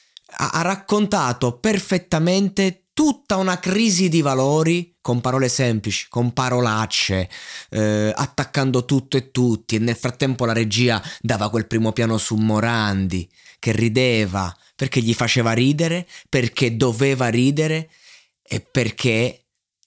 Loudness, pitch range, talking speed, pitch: -20 LUFS, 115-160 Hz, 120 wpm, 125 Hz